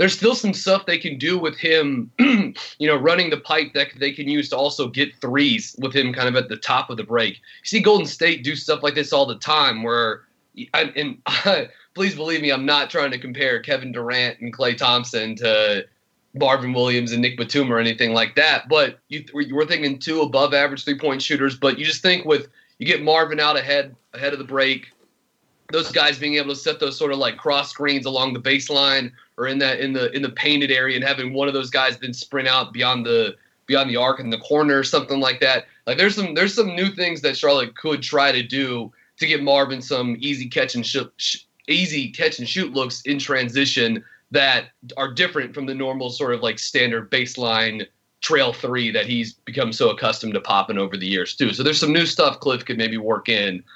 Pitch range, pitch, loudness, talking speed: 125-150 Hz, 140 Hz, -20 LUFS, 225 wpm